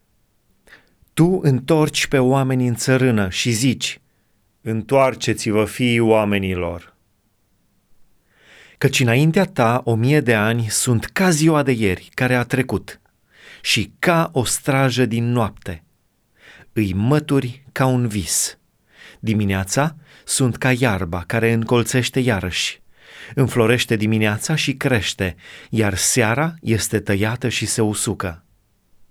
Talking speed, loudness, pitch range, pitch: 115 wpm, -19 LUFS, 105-130 Hz, 115 Hz